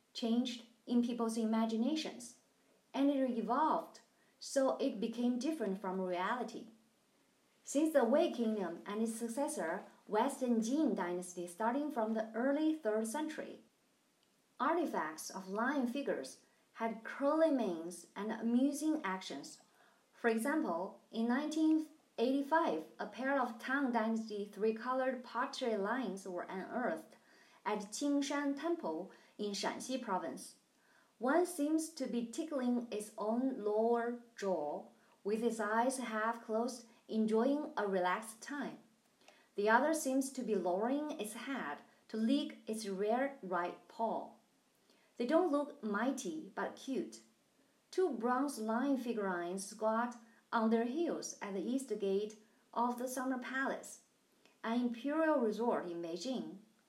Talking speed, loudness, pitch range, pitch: 125 wpm, -37 LUFS, 220-275 Hz, 235 Hz